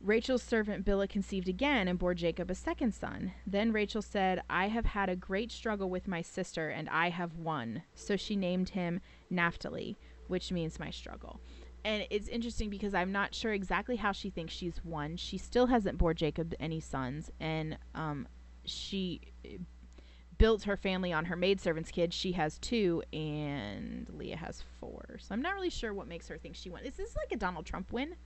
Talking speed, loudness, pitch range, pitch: 195 wpm, -35 LUFS, 165-205 Hz, 185 Hz